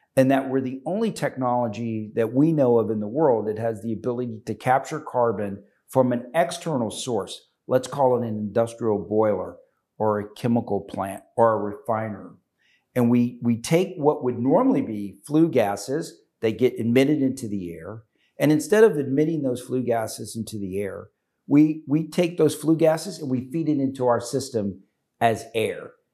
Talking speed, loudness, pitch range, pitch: 180 wpm, -23 LUFS, 110-150 Hz, 125 Hz